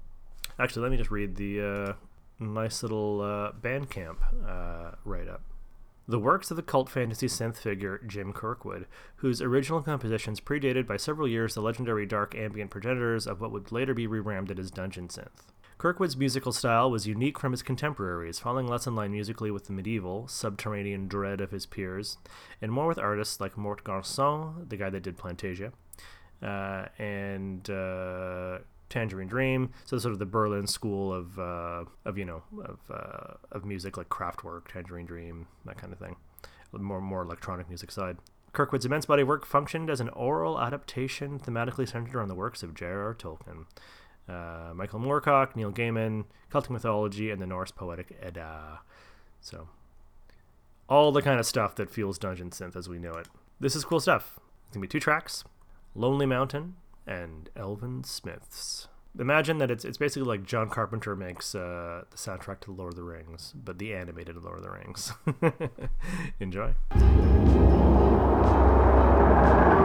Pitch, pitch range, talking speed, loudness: 105 Hz, 90-120 Hz, 165 wpm, -29 LUFS